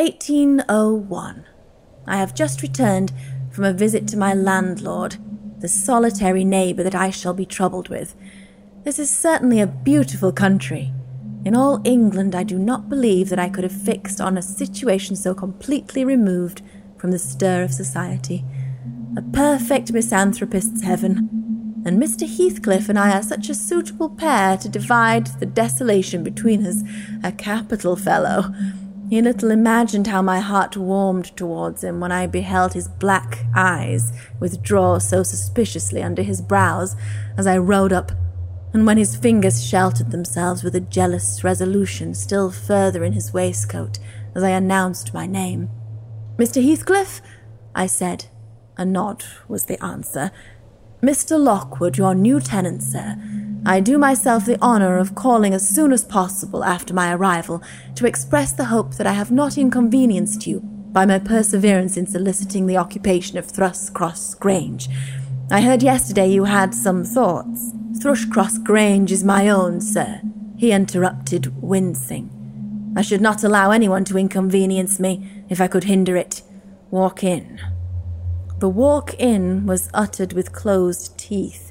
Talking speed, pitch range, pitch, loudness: 150 wpm, 130-210 Hz, 190 Hz, -19 LUFS